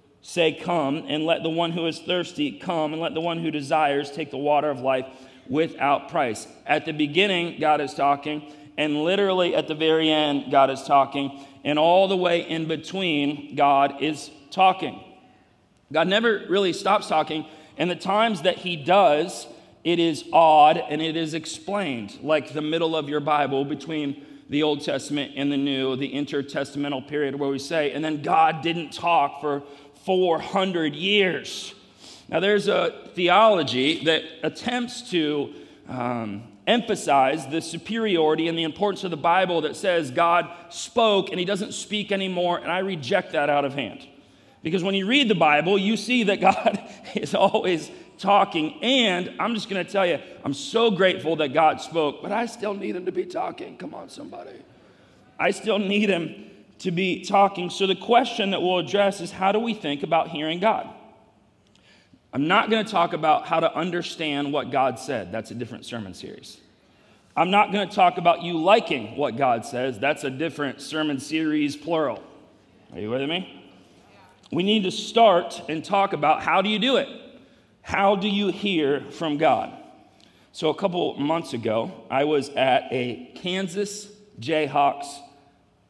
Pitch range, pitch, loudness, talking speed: 150-195 Hz, 165 Hz, -23 LUFS, 175 wpm